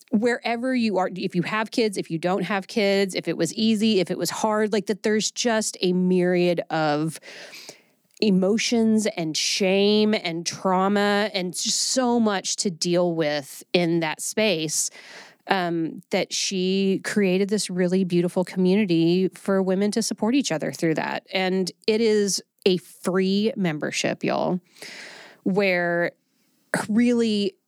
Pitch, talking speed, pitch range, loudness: 190 Hz, 145 wpm, 180-215 Hz, -23 LUFS